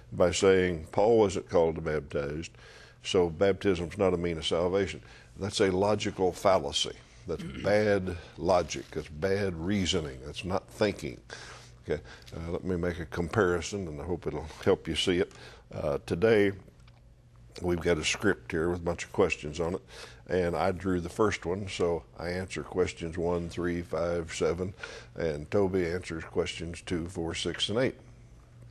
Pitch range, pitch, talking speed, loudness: 80-95 Hz, 85 Hz, 165 wpm, -30 LUFS